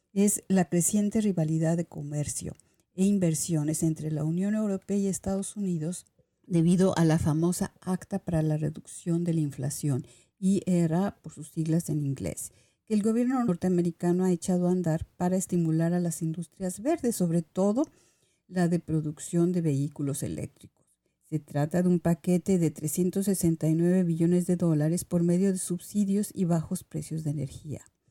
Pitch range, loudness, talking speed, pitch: 160-185 Hz, -28 LUFS, 160 wpm, 175 Hz